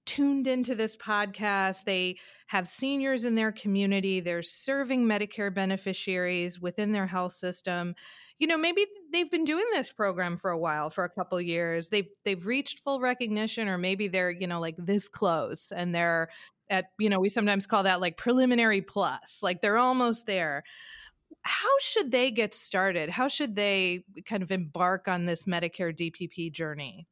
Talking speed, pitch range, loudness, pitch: 175 wpm, 180-240 Hz, -28 LUFS, 195 Hz